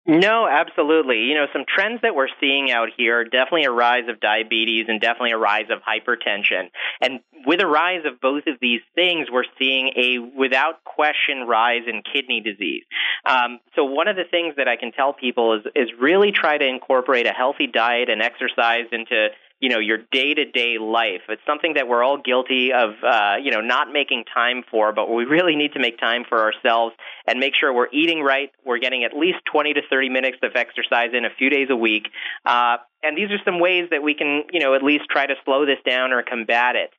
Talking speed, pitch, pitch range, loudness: 220 wpm, 130 Hz, 120-150 Hz, -19 LUFS